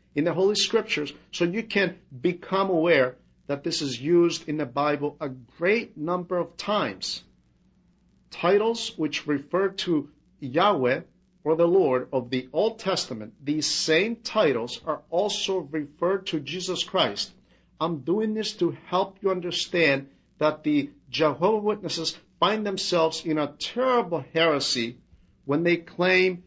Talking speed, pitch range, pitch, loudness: 140 wpm, 150-190 Hz, 165 Hz, -25 LUFS